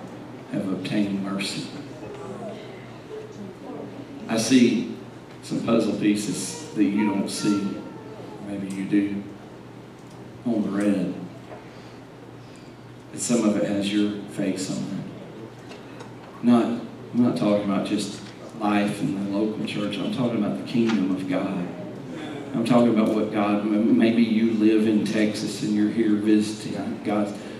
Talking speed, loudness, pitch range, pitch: 130 wpm, -24 LUFS, 100-110 Hz, 105 Hz